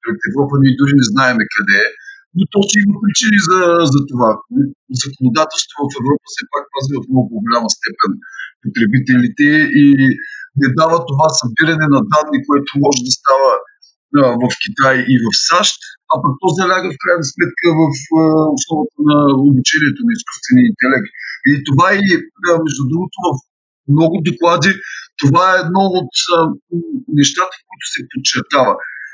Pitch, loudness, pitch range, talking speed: 155 Hz, -13 LUFS, 140-185 Hz, 160 wpm